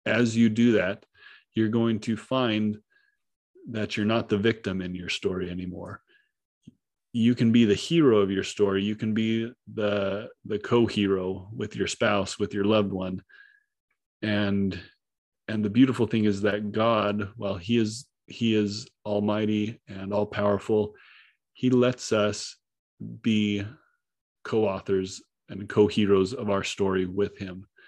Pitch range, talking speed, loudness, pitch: 100-115 Hz, 140 wpm, -26 LUFS, 105 Hz